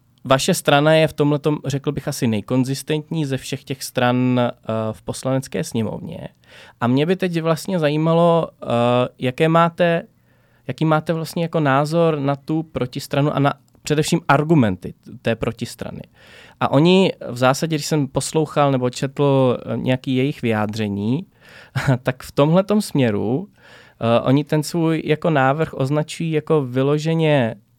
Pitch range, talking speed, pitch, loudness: 125-160 Hz, 135 wpm, 140 Hz, -19 LUFS